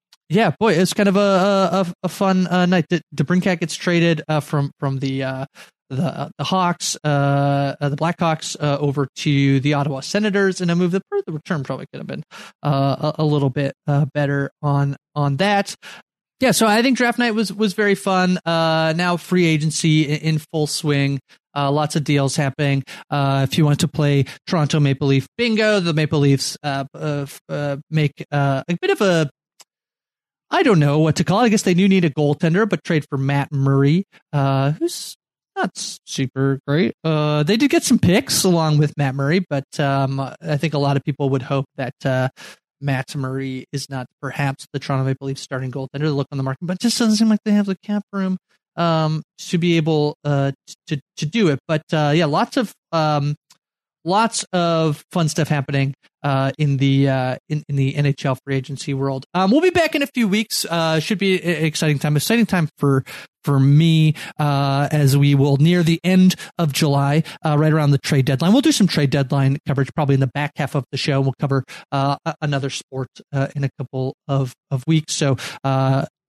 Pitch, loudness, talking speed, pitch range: 150 Hz, -19 LUFS, 205 wpm, 140-180 Hz